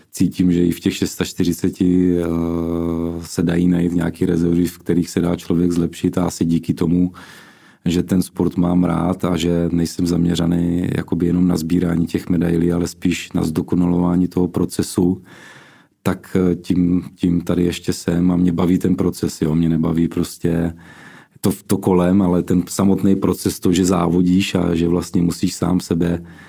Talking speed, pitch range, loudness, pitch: 165 wpm, 85-90 Hz, -18 LUFS, 90 Hz